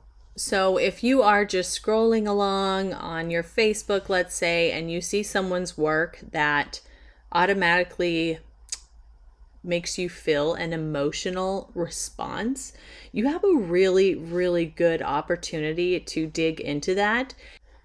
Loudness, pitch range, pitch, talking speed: -24 LUFS, 165-200 Hz, 180 Hz, 120 wpm